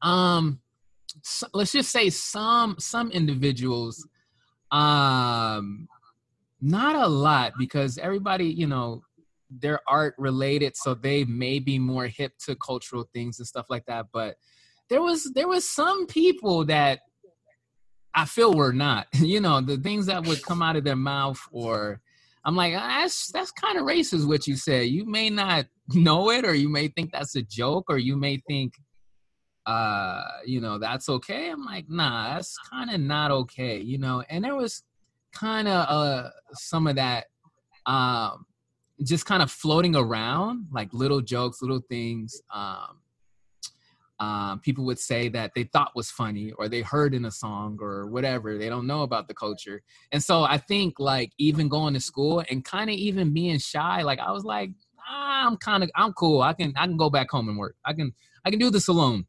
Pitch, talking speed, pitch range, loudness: 145 Hz, 185 wpm, 125-175 Hz, -25 LUFS